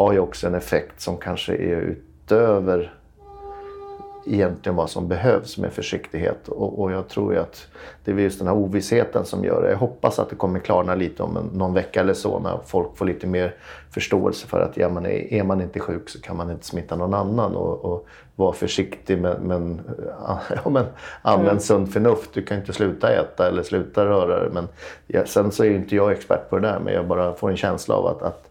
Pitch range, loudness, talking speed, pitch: 90-100 Hz, -22 LUFS, 225 wpm, 95 Hz